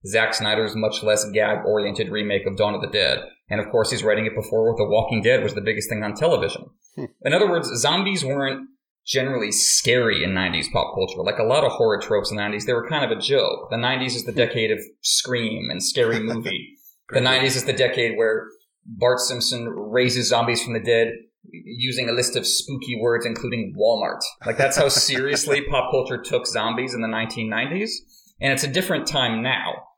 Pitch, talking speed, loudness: 125 Hz, 200 wpm, -21 LUFS